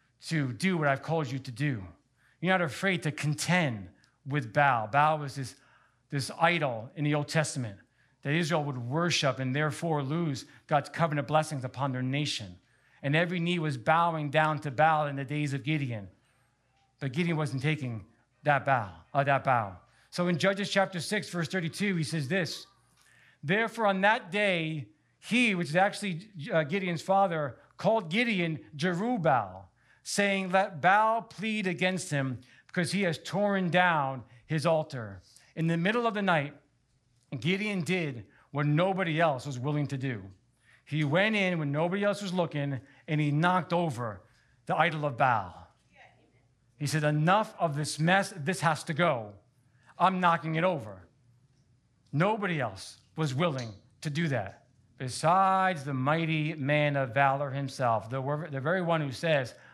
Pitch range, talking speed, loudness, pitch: 130-175 Hz, 160 wpm, -29 LUFS, 150 Hz